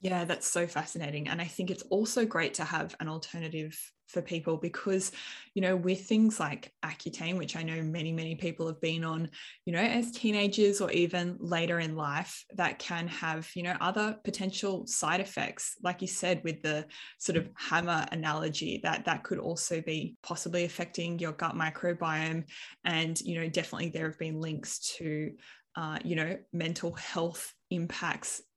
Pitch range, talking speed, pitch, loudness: 160-185 Hz, 175 wpm, 170 Hz, -33 LUFS